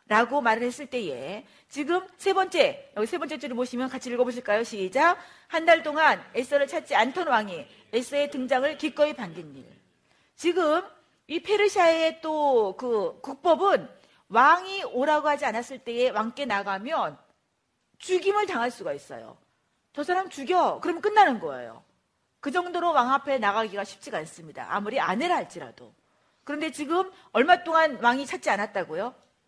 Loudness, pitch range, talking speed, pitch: -25 LUFS, 250-345 Hz, 320 characters per minute, 295 Hz